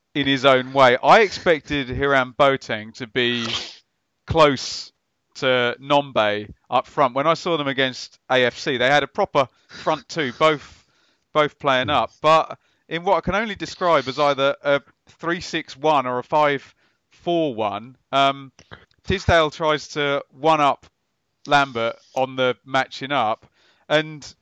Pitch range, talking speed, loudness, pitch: 130-155 Hz, 145 wpm, -20 LUFS, 140 Hz